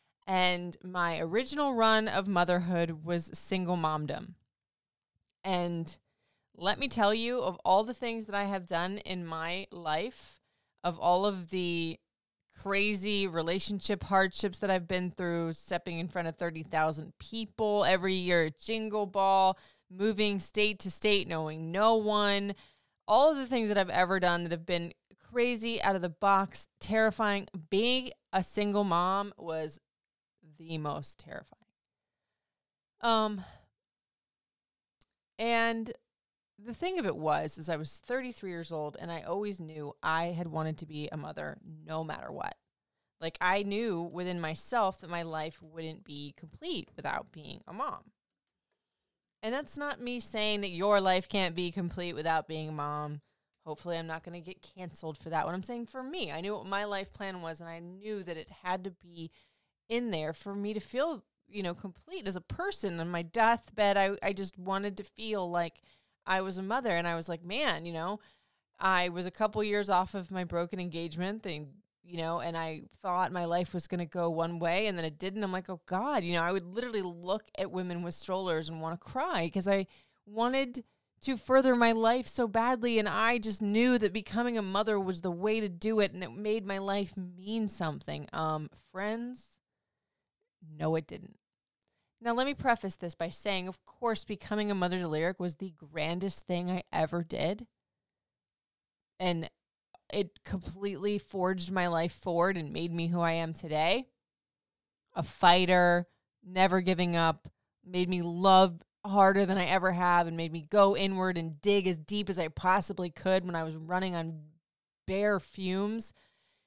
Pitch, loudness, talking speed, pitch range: 185 Hz, -31 LUFS, 175 wpm, 170-205 Hz